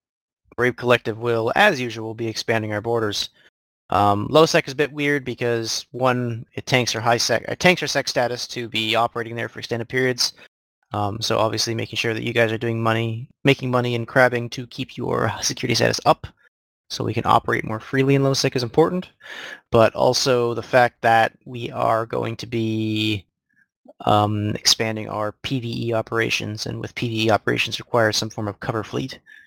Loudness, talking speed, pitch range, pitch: -21 LUFS, 185 wpm, 110-125 Hz, 115 Hz